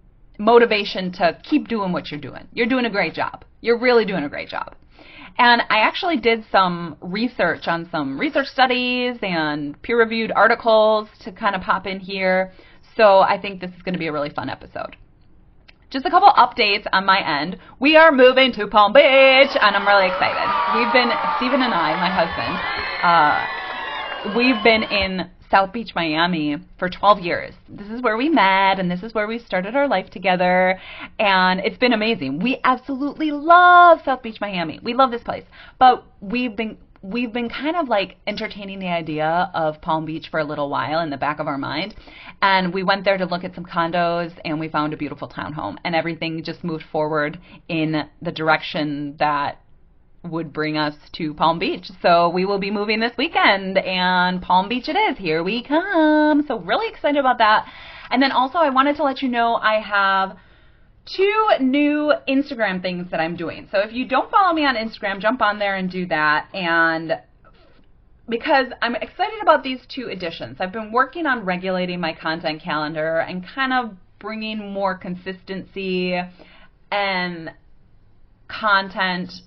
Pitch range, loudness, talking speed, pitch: 175-250 Hz, -19 LUFS, 185 wpm, 200 Hz